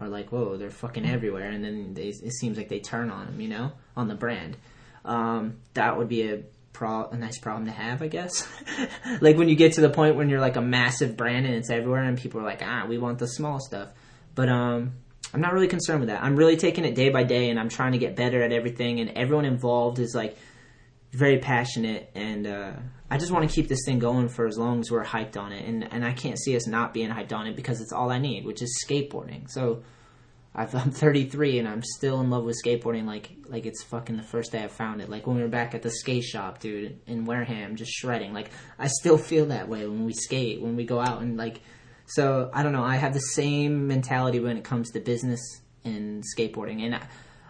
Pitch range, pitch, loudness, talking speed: 115-130 Hz, 120 Hz, -26 LUFS, 245 wpm